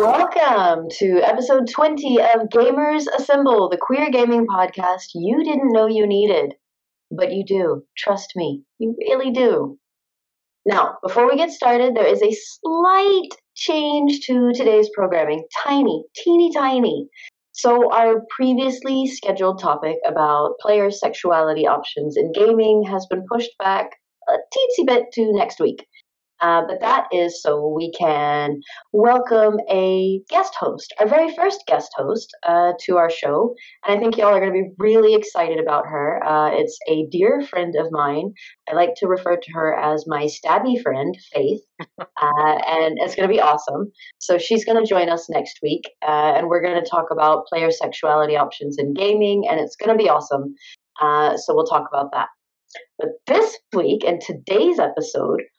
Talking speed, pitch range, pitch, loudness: 170 wpm, 165-260 Hz, 205 Hz, -18 LUFS